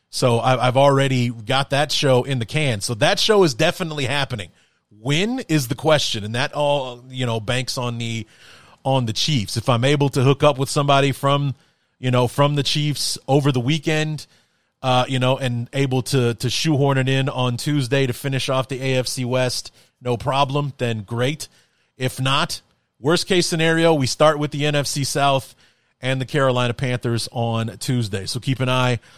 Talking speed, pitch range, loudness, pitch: 185 wpm, 125-145 Hz, -20 LUFS, 135 Hz